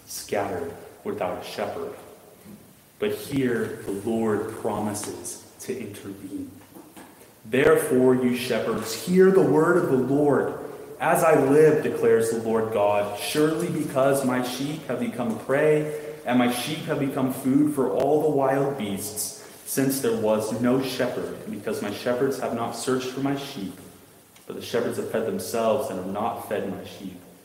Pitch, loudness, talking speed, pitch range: 130 Hz, -24 LUFS, 155 wpm, 110-140 Hz